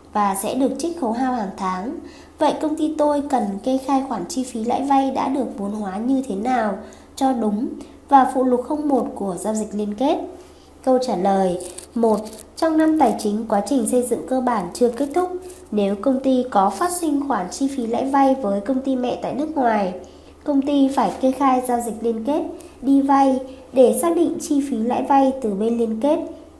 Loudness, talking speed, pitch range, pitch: -20 LUFS, 215 wpm, 225-280 Hz, 260 Hz